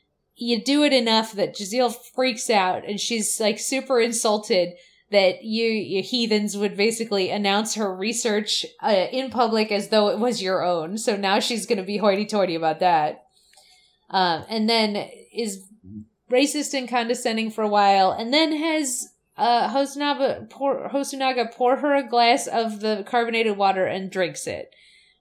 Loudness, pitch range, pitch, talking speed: -22 LUFS, 200-245 Hz, 225 Hz, 165 wpm